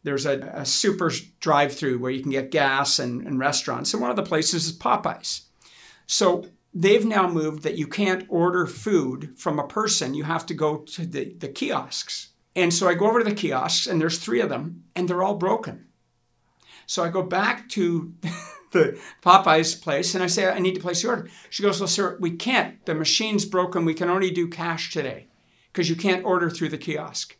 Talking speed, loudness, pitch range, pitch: 210 wpm, -23 LUFS, 155-185 Hz, 175 Hz